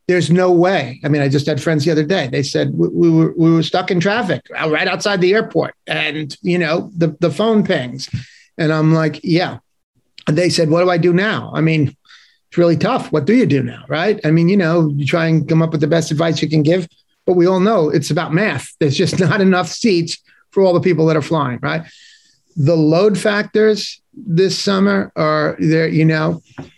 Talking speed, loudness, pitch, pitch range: 225 wpm, -15 LUFS, 165 Hz, 155-185 Hz